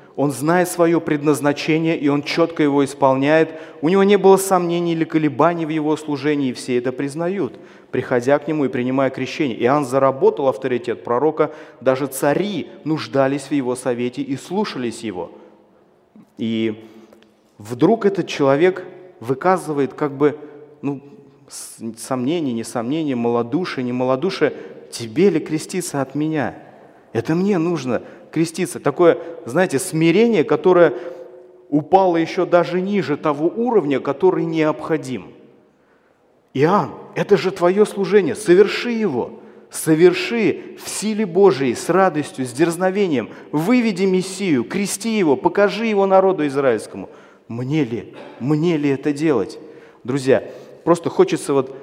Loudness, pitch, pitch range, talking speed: -19 LUFS, 155 Hz, 135-185 Hz, 125 wpm